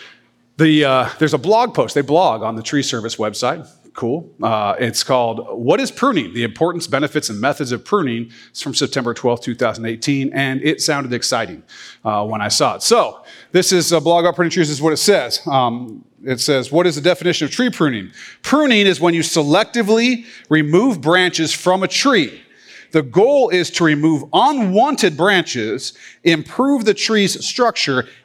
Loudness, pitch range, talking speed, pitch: -16 LUFS, 130-185 Hz, 180 wpm, 160 Hz